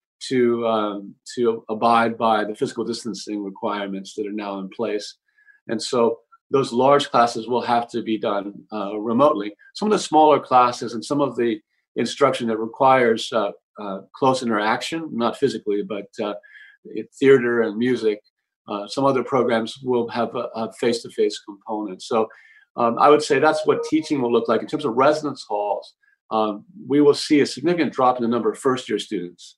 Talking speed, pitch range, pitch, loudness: 185 wpm, 110-145 Hz, 120 Hz, -21 LUFS